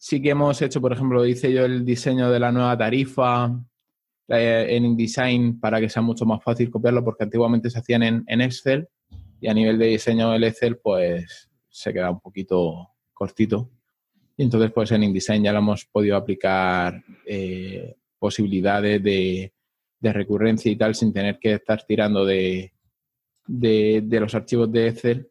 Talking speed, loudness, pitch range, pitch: 175 wpm, -21 LUFS, 105-120 Hz, 115 Hz